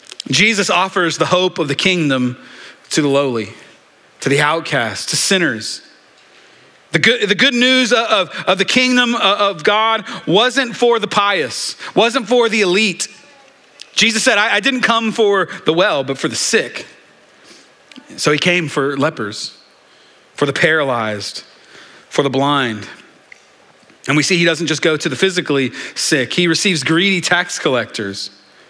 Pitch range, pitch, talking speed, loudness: 145-220 Hz, 180 Hz, 160 wpm, -15 LUFS